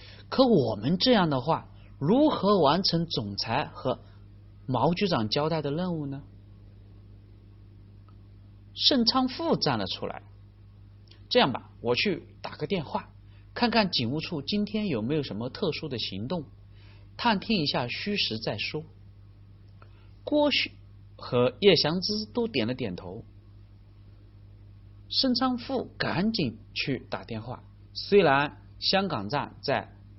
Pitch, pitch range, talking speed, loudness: 110 Hz, 100-165 Hz, 180 characters per minute, -27 LUFS